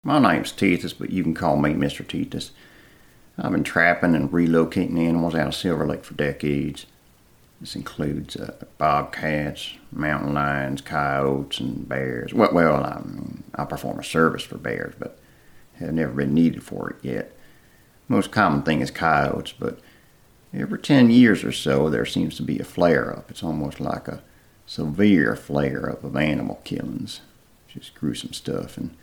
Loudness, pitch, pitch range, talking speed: -23 LUFS, 75 Hz, 70-85 Hz, 155 wpm